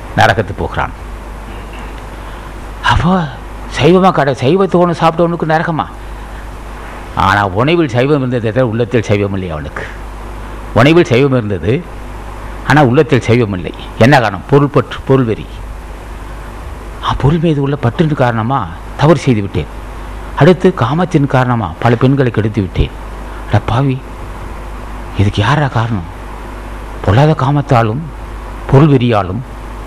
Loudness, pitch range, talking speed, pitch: -12 LUFS, 105-140 Hz, 95 wpm, 120 Hz